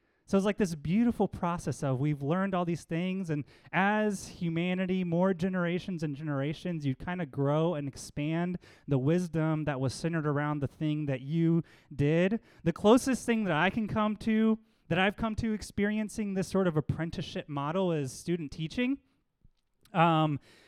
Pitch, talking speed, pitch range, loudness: 170 Hz, 170 wpm, 150-195 Hz, -31 LUFS